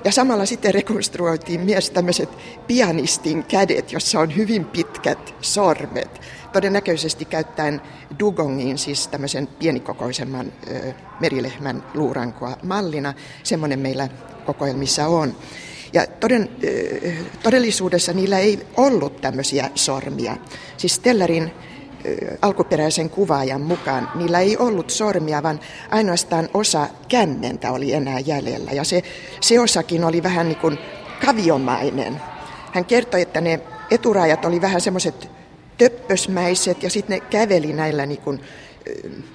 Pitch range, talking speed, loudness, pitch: 145-195 Hz, 115 wpm, -20 LUFS, 165 Hz